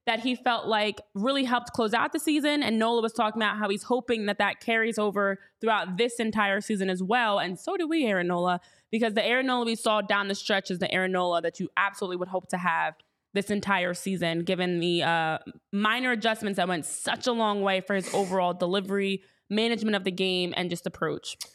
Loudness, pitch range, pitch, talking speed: -27 LUFS, 185-230 Hz, 200 Hz, 220 wpm